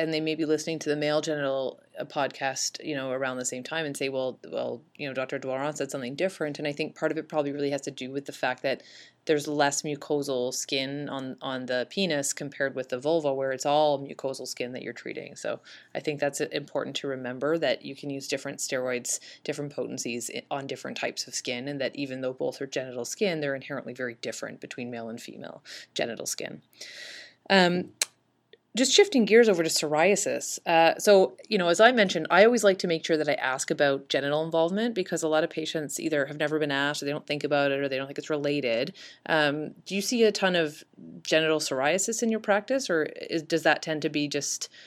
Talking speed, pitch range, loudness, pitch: 225 wpm, 135-165 Hz, -27 LUFS, 150 Hz